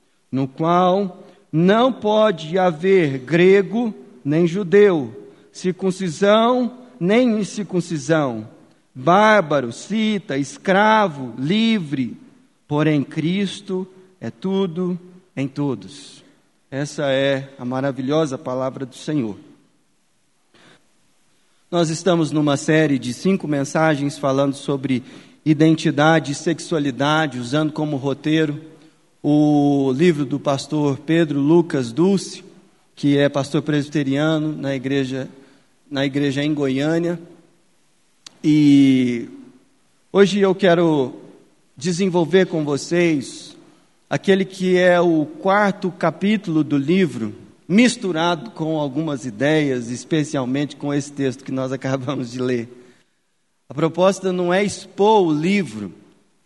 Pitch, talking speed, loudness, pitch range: 155 Hz, 100 wpm, -19 LUFS, 140-185 Hz